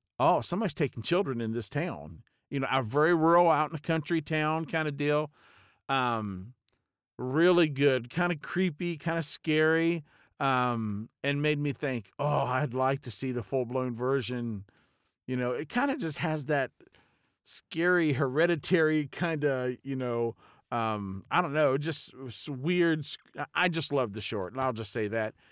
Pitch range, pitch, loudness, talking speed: 125-160 Hz, 140 Hz, -29 LUFS, 170 wpm